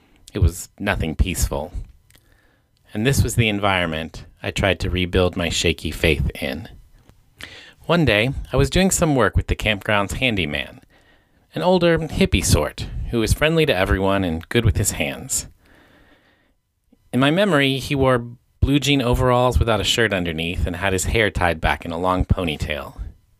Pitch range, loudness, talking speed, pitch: 90-125 Hz, -20 LUFS, 165 wpm, 100 Hz